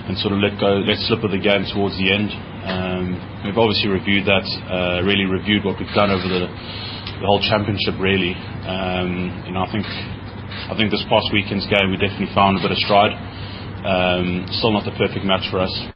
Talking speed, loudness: 210 wpm, -19 LUFS